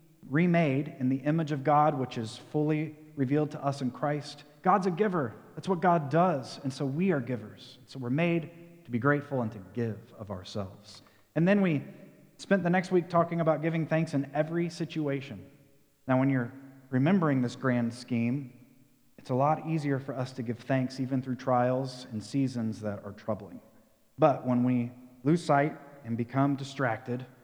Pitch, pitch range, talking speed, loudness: 135 Hz, 125-155 Hz, 180 wpm, -30 LUFS